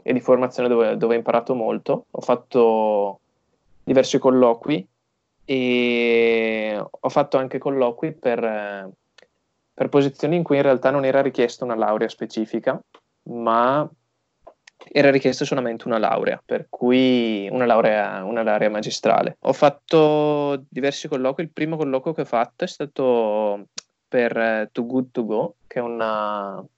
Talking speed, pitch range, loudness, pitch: 140 wpm, 110-135 Hz, -21 LUFS, 125 Hz